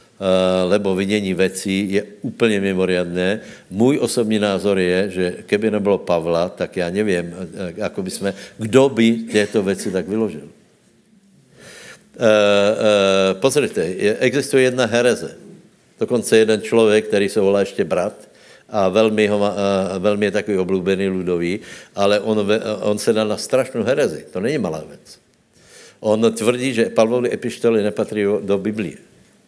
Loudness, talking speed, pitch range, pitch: -18 LUFS, 125 wpm, 95-110 Hz, 105 Hz